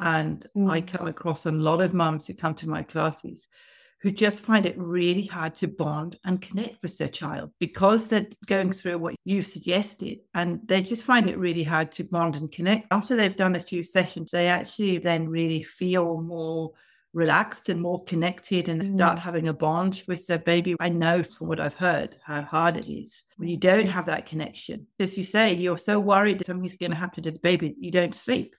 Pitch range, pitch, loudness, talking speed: 165-190 Hz, 175 Hz, -25 LUFS, 210 wpm